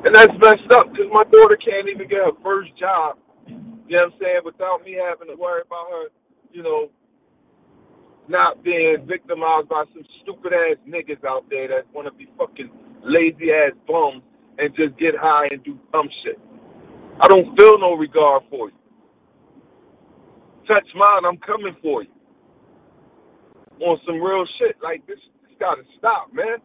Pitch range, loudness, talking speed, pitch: 165-265 Hz, -17 LUFS, 175 wpm, 190 Hz